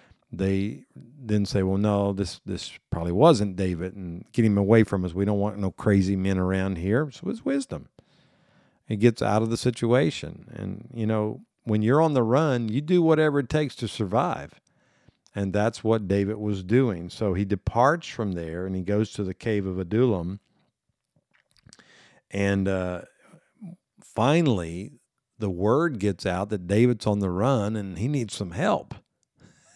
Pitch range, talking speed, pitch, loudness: 95-120 Hz, 170 wpm, 105 Hz, -25 LUFS